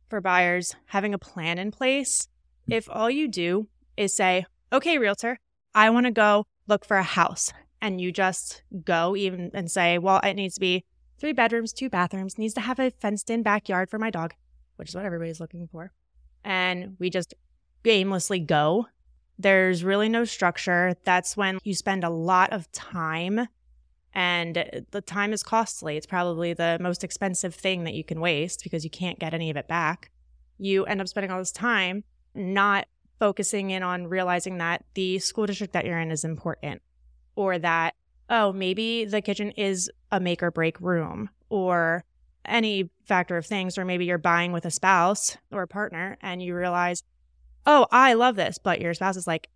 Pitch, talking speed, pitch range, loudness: 185 Hz, 190 wpm, 170-205 Hz, -25 LUFS